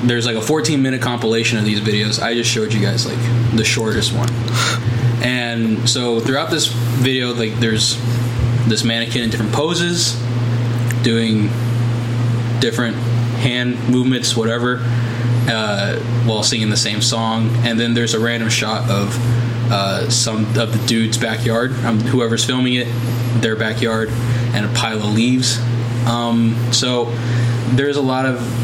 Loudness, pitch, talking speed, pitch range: -17 LUFS, 120 Hz, 150 wpm, 115-120 Hz